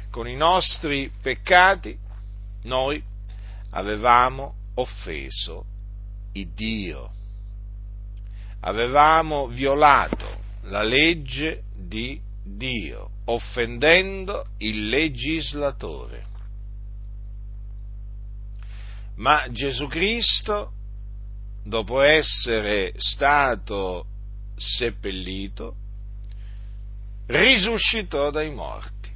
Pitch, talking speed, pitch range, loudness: 100 Hz, 60 wpm, 100-135 Hz, -20 LUFS